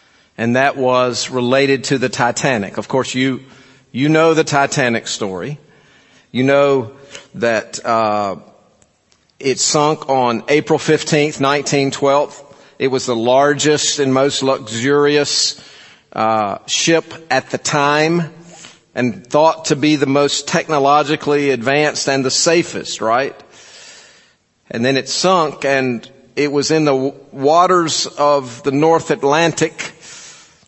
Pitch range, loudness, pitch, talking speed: 130-150 Hz, -15 LUFS, 140 Hz, 125 wpm